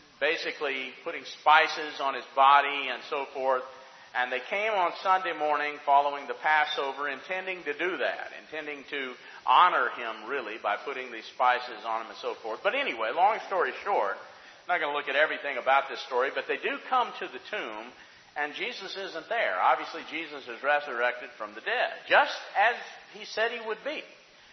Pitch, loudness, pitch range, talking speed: 145 Hz, -28 LUFS, 135-180 Hz, 185 wpm